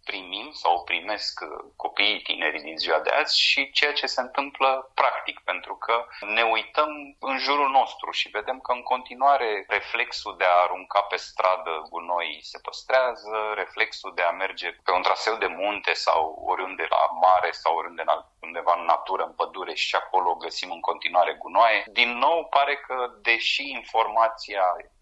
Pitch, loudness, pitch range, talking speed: 115 Hz, -24 LUFS, 95-135 Hz, 170 wpm